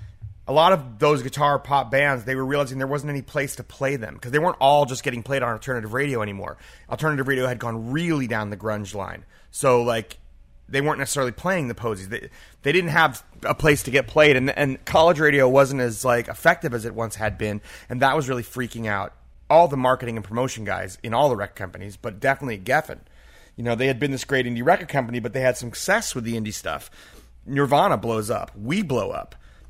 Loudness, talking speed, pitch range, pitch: -22 LUFS, 225 wpm, 110-140 Hz, 130 Hz